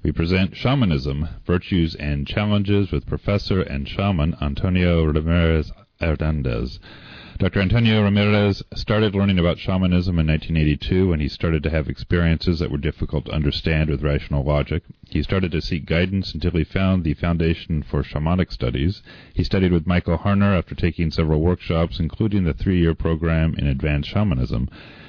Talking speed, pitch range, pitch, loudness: 155 wpm, 75-95 Hz, 85 Hz, -21 LUFS